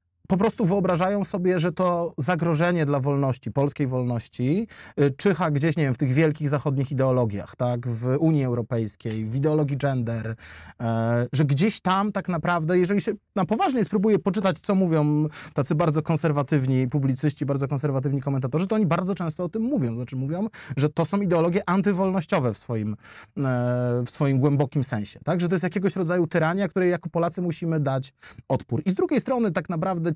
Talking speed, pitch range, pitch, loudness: 170 wpm, 135-185 Hz, 155 Hz, -24 LUFS